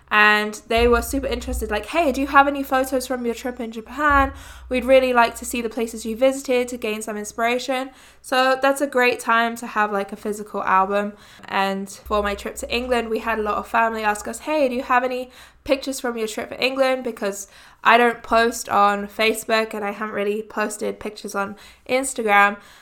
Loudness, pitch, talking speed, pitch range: -21 LUFS, 230 Hz, 210 wpm, 210-255 Hz